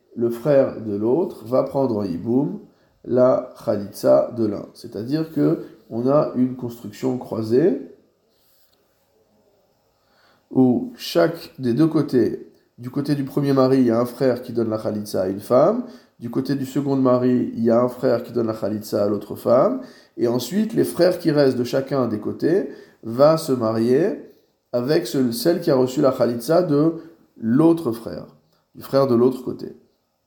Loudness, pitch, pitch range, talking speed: -20 LUFS, 125 Hz, 115-140 Hz, 170 wpm